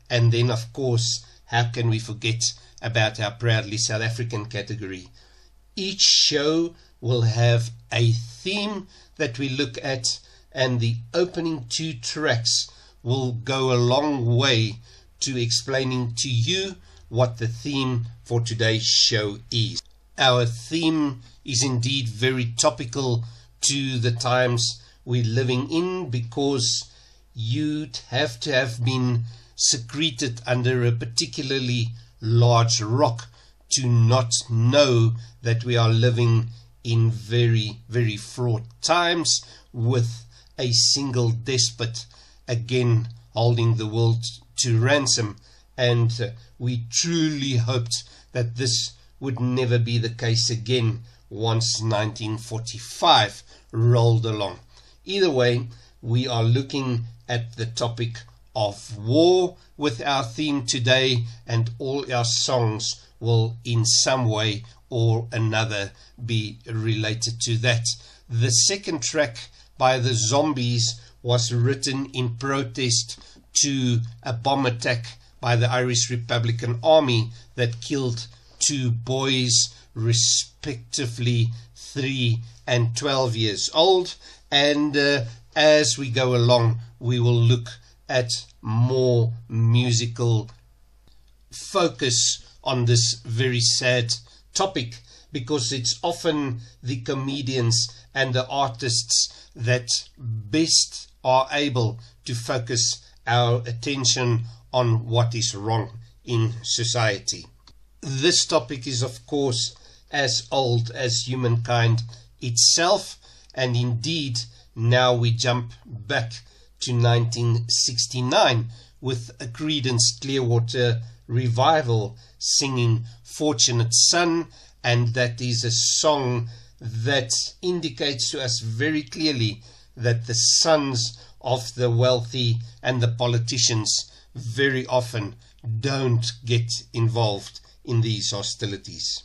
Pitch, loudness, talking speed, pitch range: 120 Hz, -22 LUFS, 110 wpm, 115-130 Hz